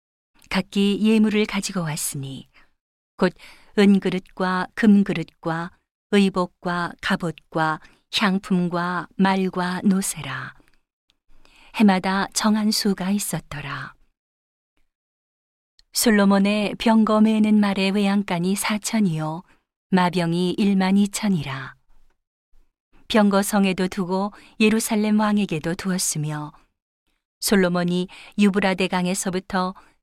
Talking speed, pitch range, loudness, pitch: 210 characters per minute, 175-205 Hz, -21 LUFS, 190 Hz